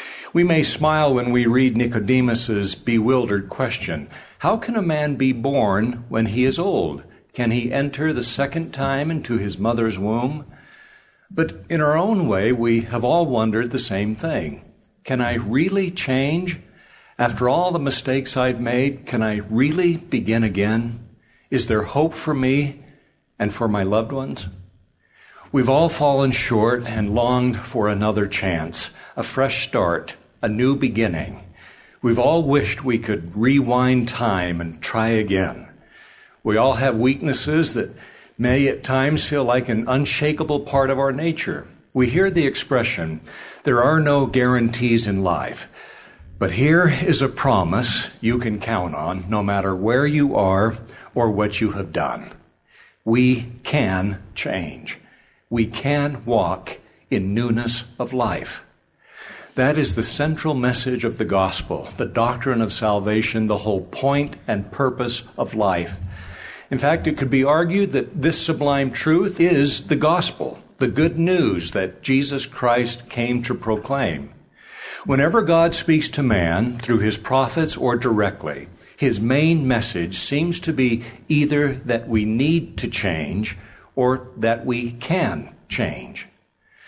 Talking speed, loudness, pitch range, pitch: 150 wpm, -20 LUFS, 110-145 Hz, 125 Hz